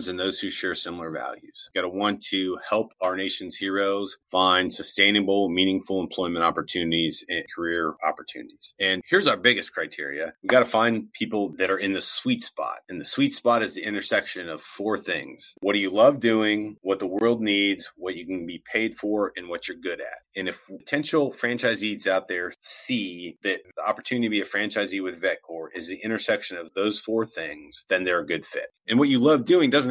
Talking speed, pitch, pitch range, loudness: 205 wpm, 100 Hz, 95-115 Hz, -25 LUFS